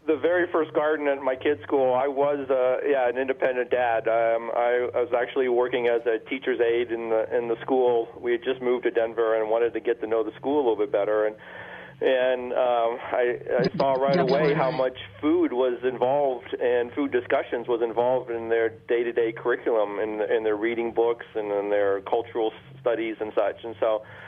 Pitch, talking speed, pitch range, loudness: 120 Hz, 210 wpm, 115-130 Hz, -25 LUFS